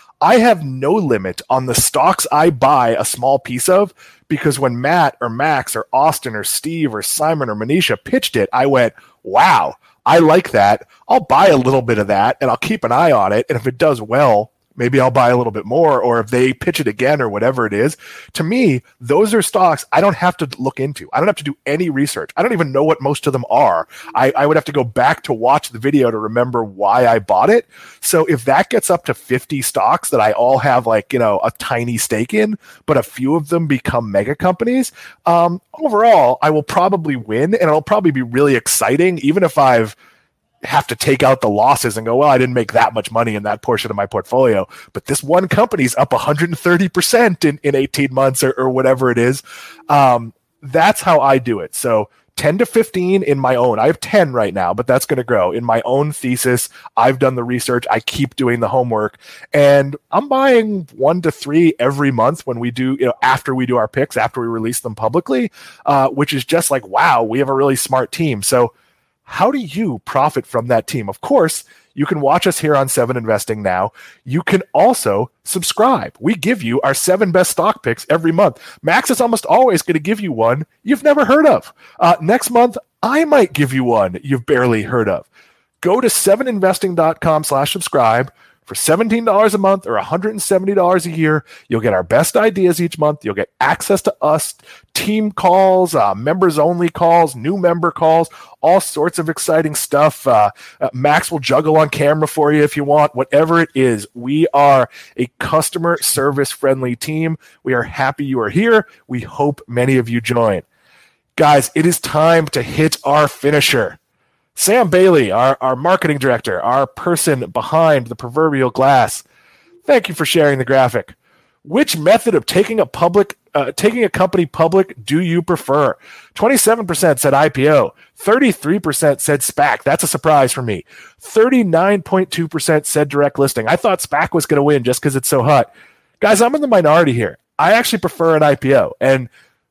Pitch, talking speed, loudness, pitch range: 150 Hz, 205 wpm, -14 LUFS, 130-180 Hz